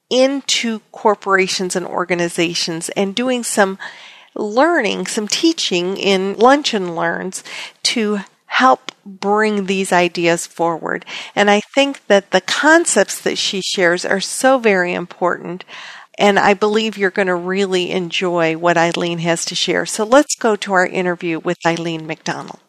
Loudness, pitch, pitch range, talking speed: -16 LUFS, 195 Hz, 175-215 Hz, 145 wpm